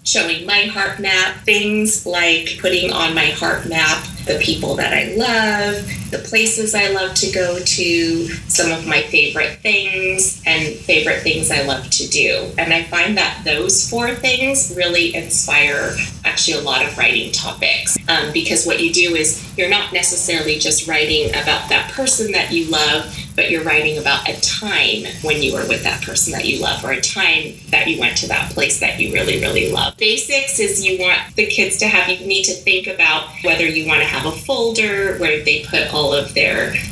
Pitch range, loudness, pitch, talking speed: 160-205 Hz, -15 LUFS, 180 Hz, 200 wpm